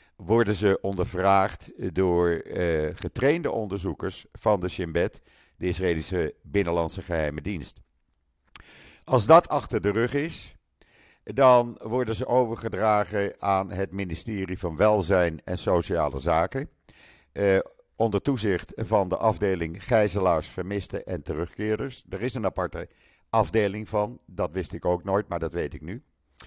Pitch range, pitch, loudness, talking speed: 90-110 Hz, 95 Hz, -26 LUFS, 135 wpm